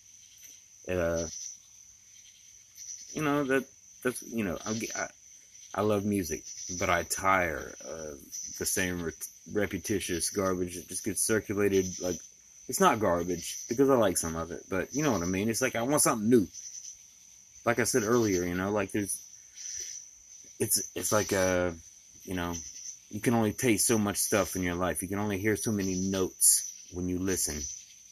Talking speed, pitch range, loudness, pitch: 175 wpm, 90-105 Hz, -29 LUFS, 95 Hz